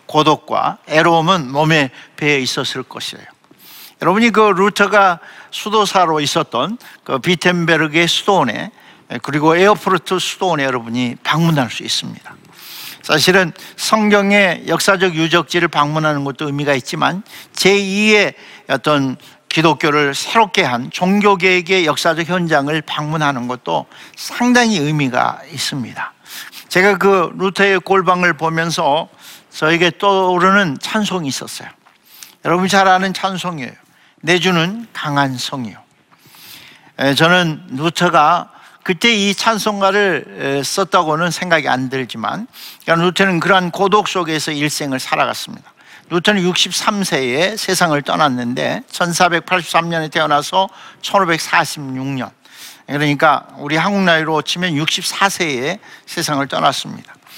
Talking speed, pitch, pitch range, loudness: 280 characters per minute, 170 Hz, 150-195 Hz, -15 LUFS